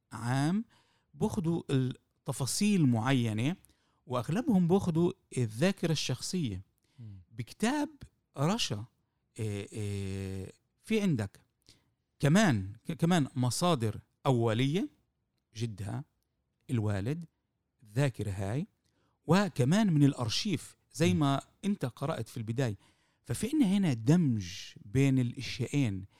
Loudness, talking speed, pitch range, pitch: -31 LUFS, 80 wpm, 115-165 Hz, 135 Hz